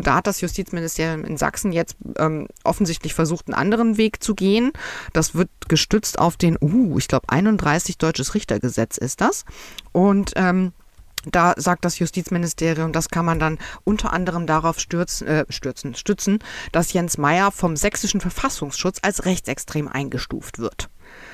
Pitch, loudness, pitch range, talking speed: 175 Hz, -21 LUFS, 155-195 Hz, 155 wpm